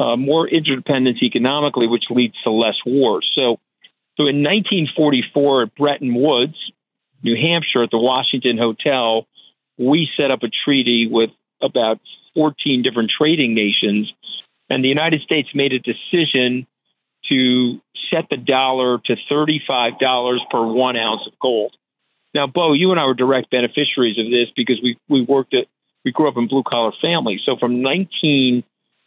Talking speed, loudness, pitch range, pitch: 165 wpm, -17 LUFS, 120-145 Hz, 130 Hz